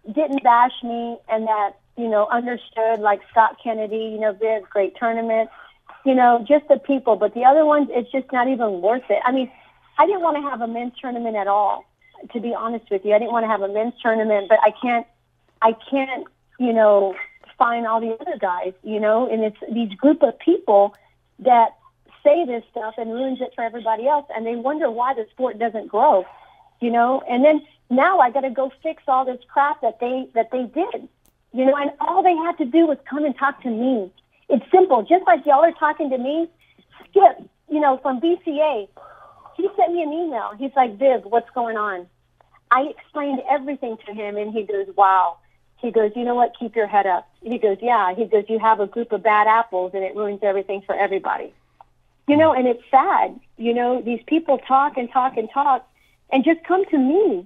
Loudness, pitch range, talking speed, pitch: -20 LUFS, 220-280 Hz, 215 wpm, 240 Hz